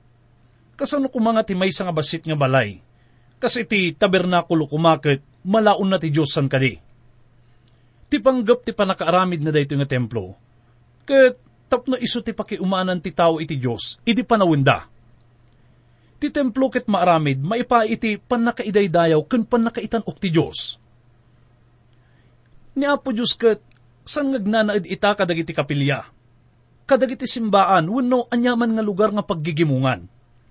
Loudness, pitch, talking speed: -20 LUFS, 170 Hz, 130 wpm